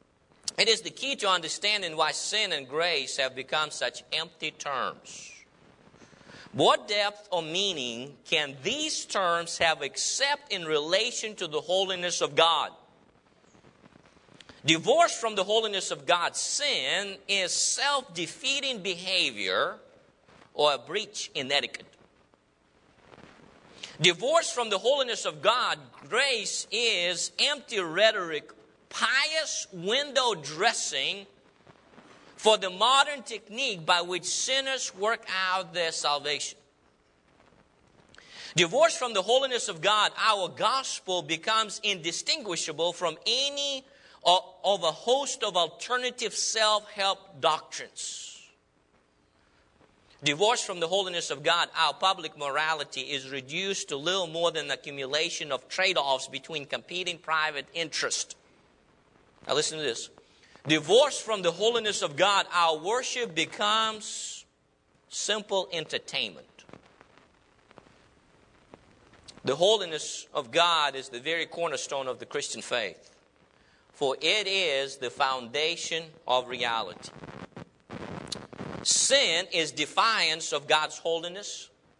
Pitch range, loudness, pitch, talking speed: 155-220 Hz, -27 LUFS, 180 Hz, 115 wpm